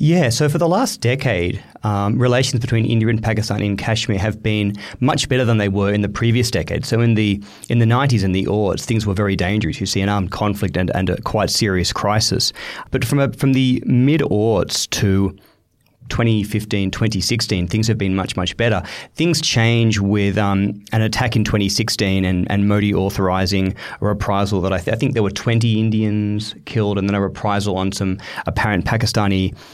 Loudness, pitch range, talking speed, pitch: -18 LUFS, 100-115 Hz, 195 wpm, 105 Hz